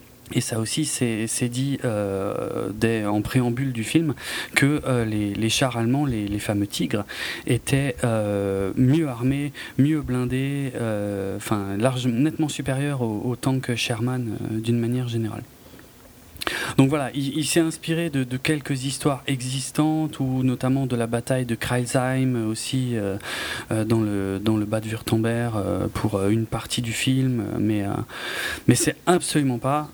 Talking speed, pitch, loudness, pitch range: 160 wpm, 125 Hz, -24 LUFS, 110-135 Hz